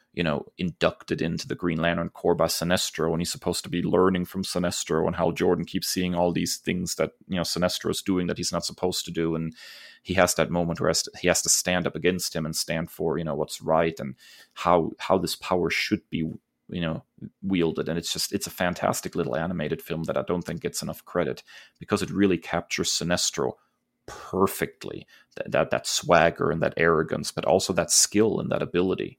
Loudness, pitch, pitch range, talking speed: -25 LUFS, 85 Hz, 80-90 Hz, 215 wpm